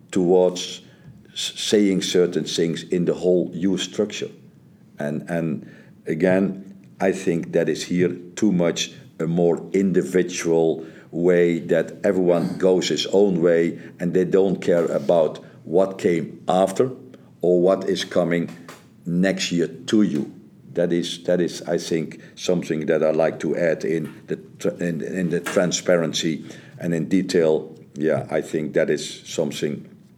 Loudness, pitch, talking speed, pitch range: -22 LUFS, 90 Hz, 145 wpm, 85-95 Hz